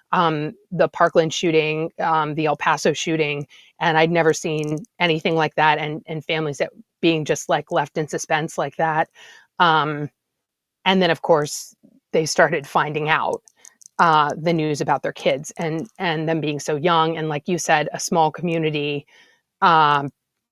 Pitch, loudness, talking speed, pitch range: 160 Hz, -20 LUFS, 165 wpm, 150-165 Hz